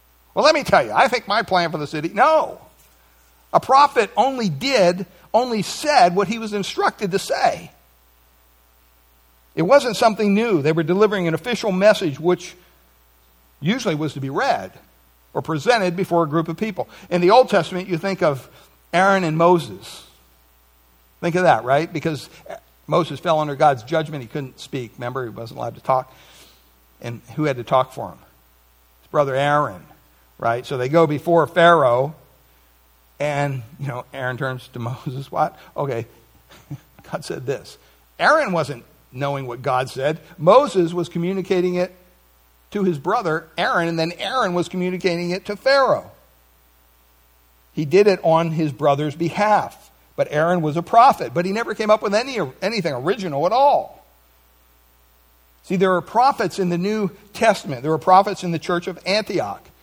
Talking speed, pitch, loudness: 165 wpm, 155 Hz, -19 LUFS